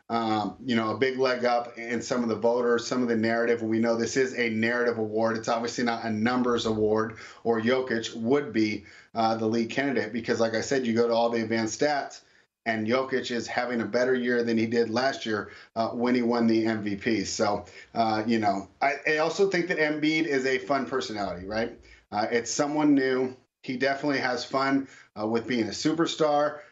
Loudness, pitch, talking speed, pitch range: -27 LUFS, 120 Hz, 210 wpm, 115-130 Hz